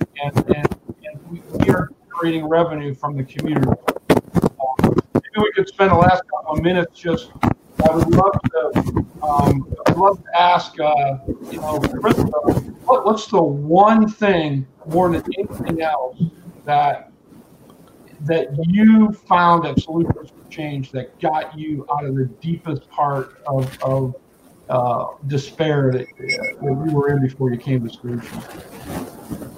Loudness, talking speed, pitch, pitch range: -19 LUFS, 150 wpm, 155 Hz, 140-175 Hz